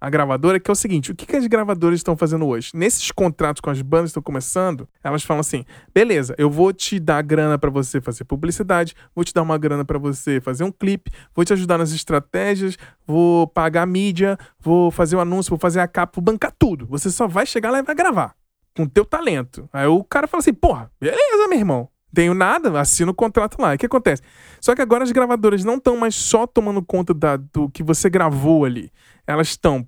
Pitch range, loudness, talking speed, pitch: 150-205 Hz, -19 LUFS, 230 wpm, 170 Hz